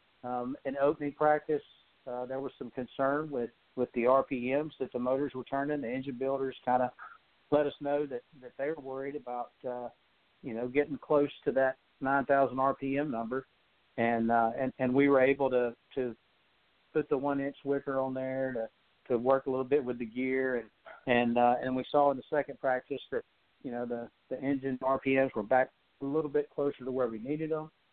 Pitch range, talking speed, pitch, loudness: 125-140 Hz, 205 wpm, 135 Hz, -32 LUFS